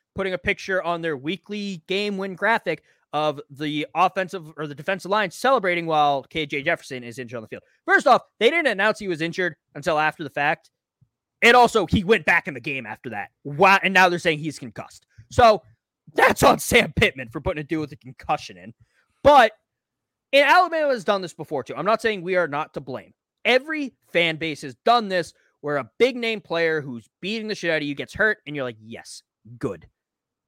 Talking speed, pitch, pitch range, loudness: 215 wpm, 170 Hz, 145-205 Hz, -21 LUFS